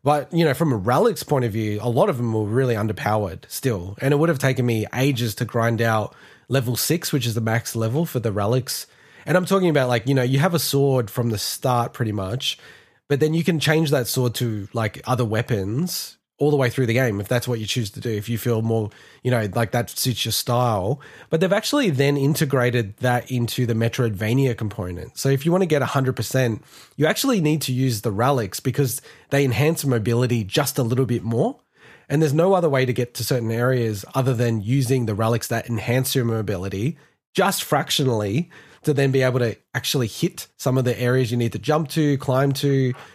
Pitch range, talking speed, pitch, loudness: 115-145 Hz, 220 wpm, 125 Hz, -22 LUFS